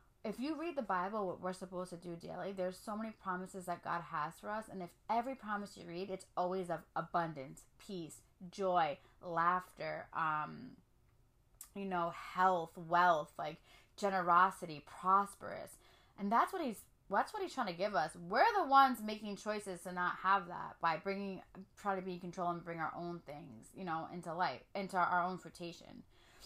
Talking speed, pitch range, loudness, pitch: 185 wpm, 170-200 Hz, -38 LUFS, 180 Hz